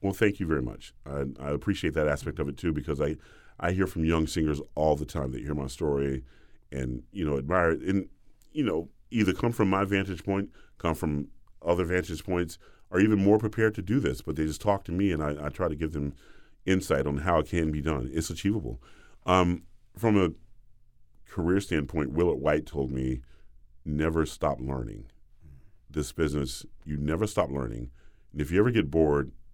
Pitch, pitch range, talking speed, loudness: 80 Hz, 70-95 Hz, 200 wpm, -29 LUFS